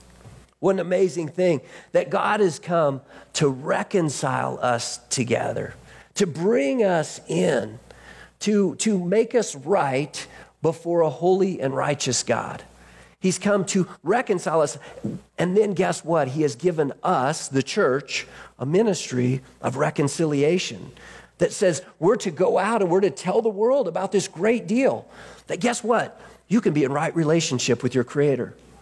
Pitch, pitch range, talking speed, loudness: 170 Hz, 140-200 Hz, 155 wpm, -23 LUFS